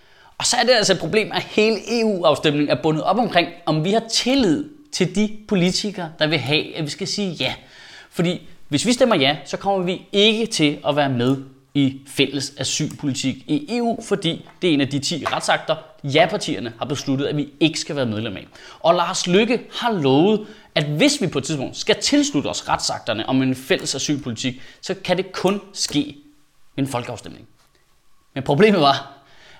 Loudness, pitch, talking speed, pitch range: -20 LUFS, 160 Hz, 195 wpm, 140-205 Hz